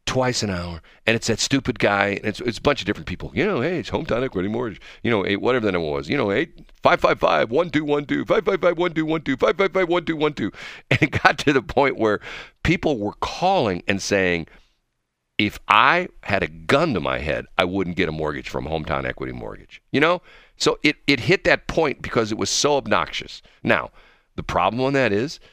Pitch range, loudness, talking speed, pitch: 90-145 Hz, -21 LUFS, 245 wpm, 110 Hz